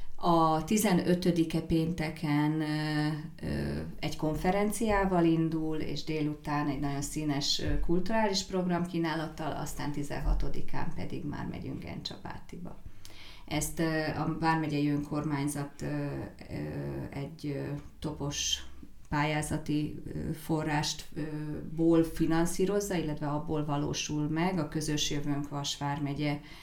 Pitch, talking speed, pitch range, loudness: 150 Hz, 85 wpm, 145-165 Hz, -32 LUFS